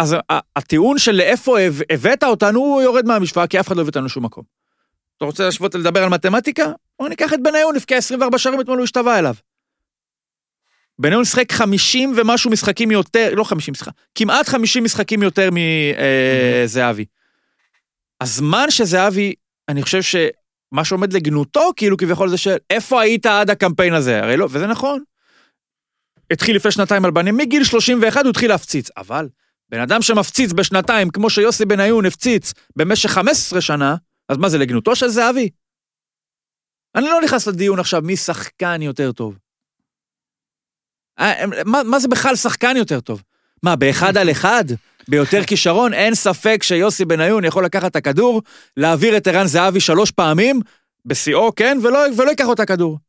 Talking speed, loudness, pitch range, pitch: 160 wpm, -15 LUFS, 170-240 Hz, 200 Hz